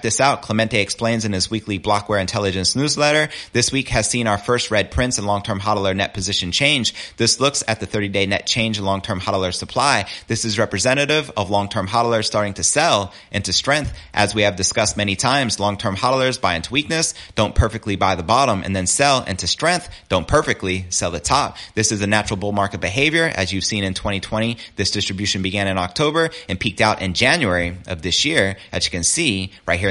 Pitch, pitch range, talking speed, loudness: 105 Hz, 95-115 Hz, 215 wpm, -19 LUFS